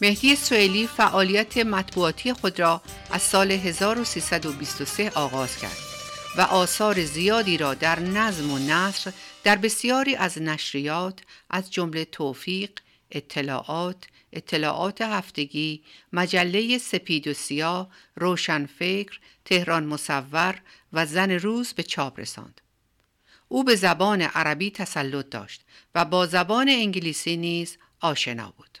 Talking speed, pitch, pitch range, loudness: 115 wpm, 180 Hz, 155-205 Hz, -24 LUFS